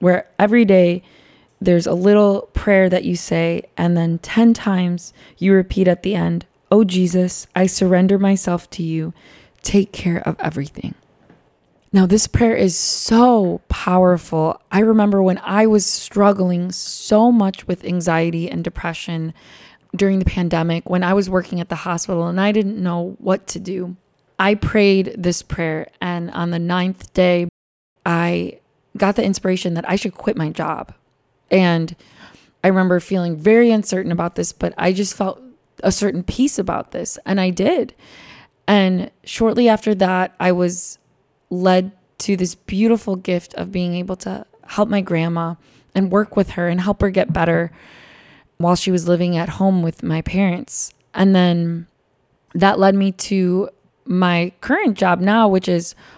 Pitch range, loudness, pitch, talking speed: 170-195 Hz, -18 LUFS, 185 Hz, 160 wpm